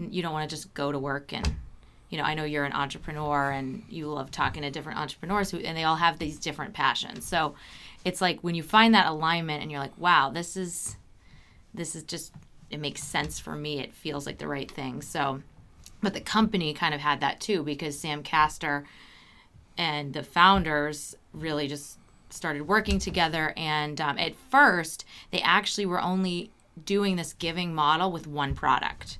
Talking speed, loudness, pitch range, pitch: 195 wpm, -27 LUFS, 145-175 Hz, 155 Hz